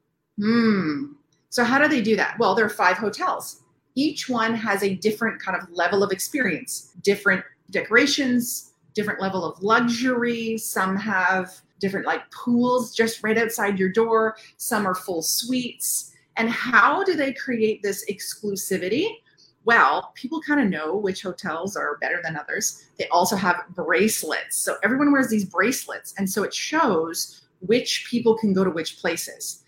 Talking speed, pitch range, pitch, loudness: 160 wpm, 185-240 Hz, 210 Hz, -23 LUFS